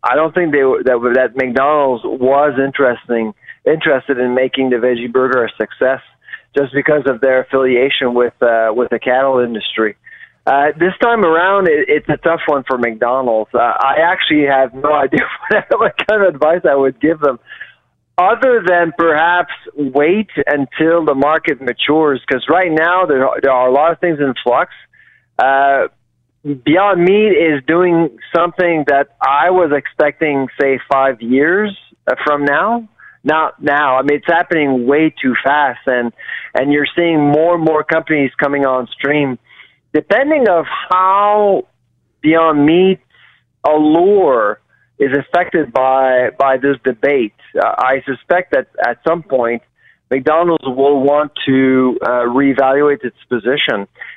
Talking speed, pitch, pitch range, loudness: 155 wpm, 145 Hz, 130-165 Hz, -13 LUFS